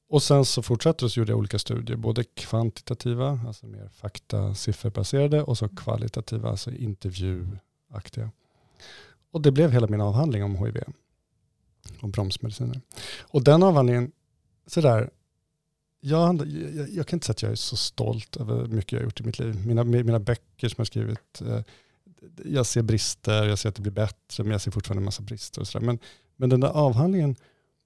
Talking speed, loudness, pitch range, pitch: 180 wpm, -25 LUFS, 105-130 Hz, 115 Hz